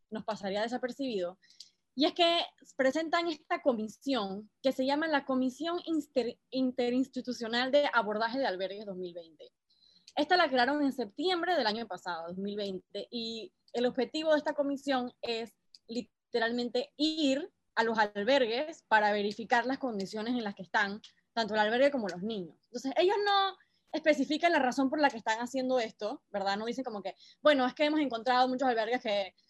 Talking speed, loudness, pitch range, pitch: 165 wpm, -31 LUFS, 220-285 Hz, 250 Hz